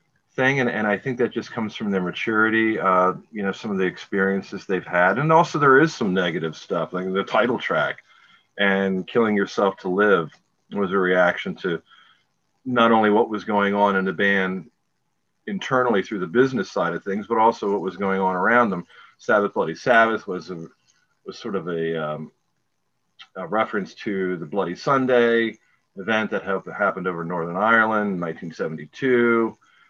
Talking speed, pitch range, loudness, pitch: 175 wpm, 95-110 Hz, -21 LUFS, 100 Hz